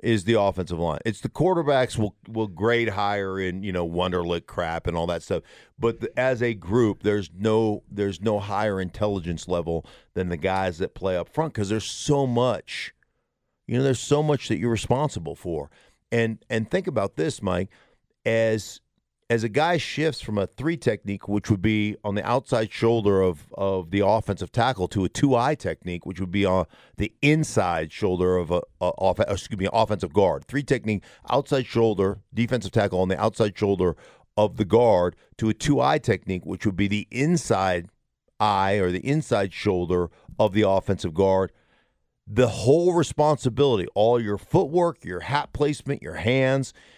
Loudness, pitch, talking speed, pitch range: -24 LUFS, 105 Hz, 180 wpm, 95-125 Hz